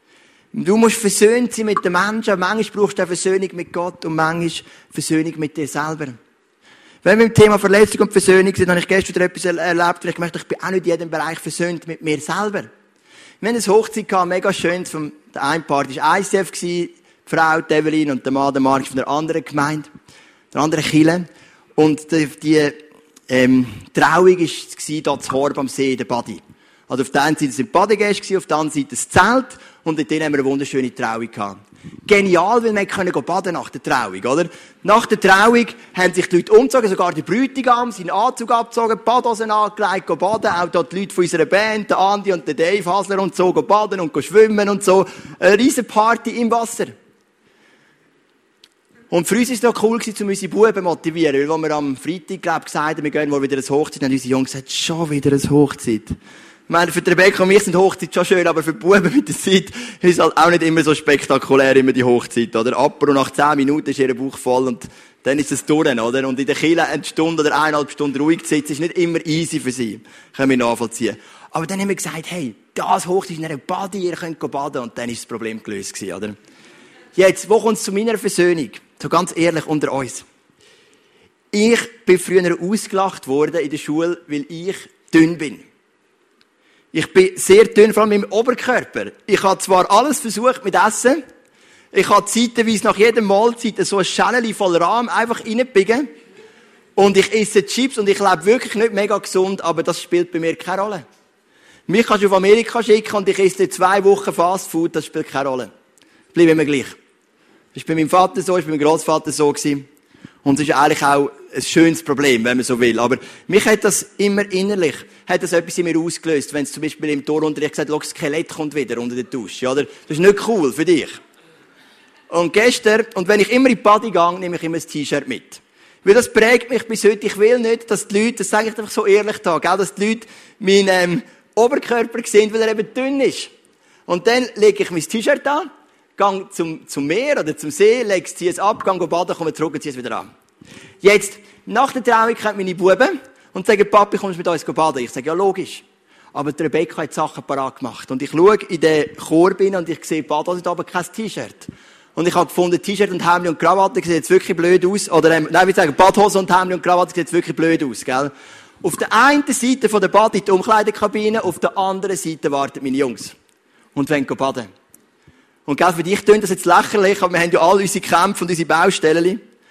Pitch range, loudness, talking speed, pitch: 155-210 Hz, -17 LUFS, 215 wpm, 180 Hz